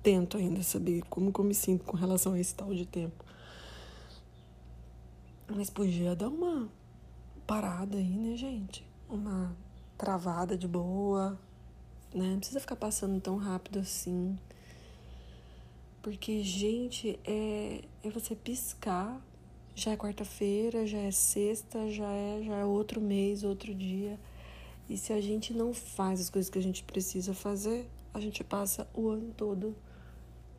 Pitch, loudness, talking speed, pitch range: 195 Hz, -34 LUFS, 145 wpm, 175-210 Hz